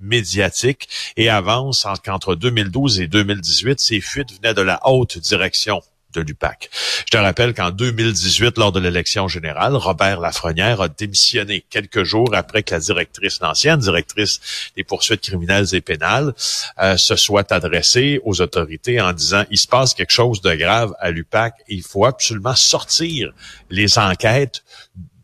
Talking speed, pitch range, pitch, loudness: 155 wpm, 95-120 Hz, 105 Hz, -16 LUFS